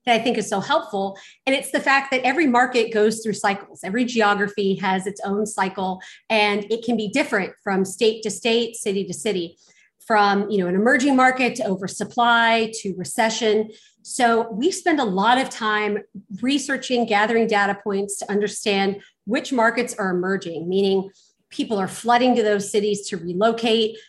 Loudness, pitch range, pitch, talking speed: -21 LUFS, 200-235 Hz, 215 Hz, 175 wpm